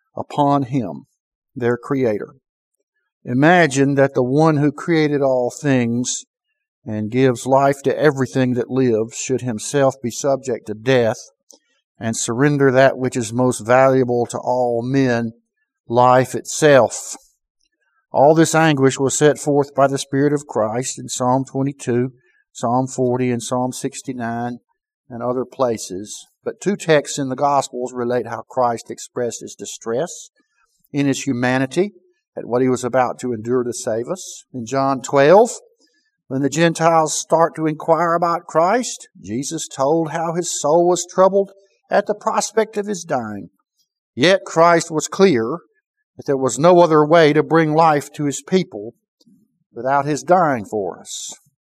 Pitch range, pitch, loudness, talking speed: 125-170 Hz, 140 Hz, -18 LUFS, 150 wpm